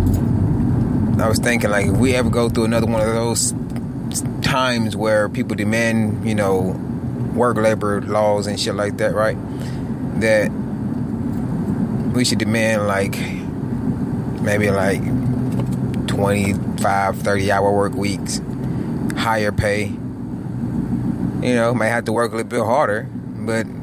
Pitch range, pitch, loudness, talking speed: 105-120 Hz, 110 Hz, -19 LUFS, 130 wpm